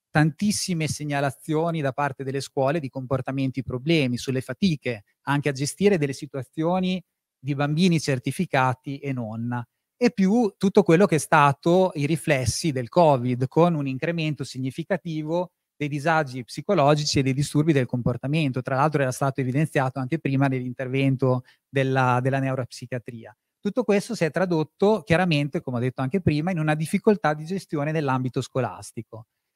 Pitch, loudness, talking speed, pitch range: 145 Hz, -24 LUFS, 150 wpm, 130-165 Hz